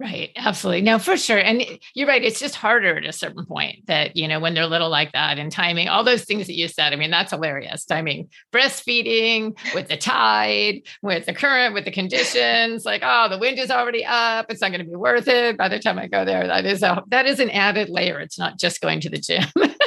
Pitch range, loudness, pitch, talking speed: 170-240 Hz, -19 LUFS, 205 Hz, 250 wpm